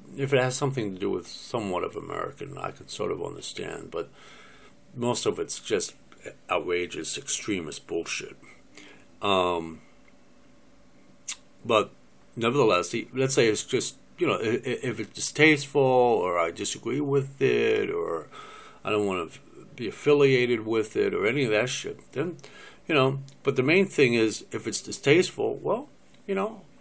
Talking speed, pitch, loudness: 150 wpm, 135 Hz, -26 LUFS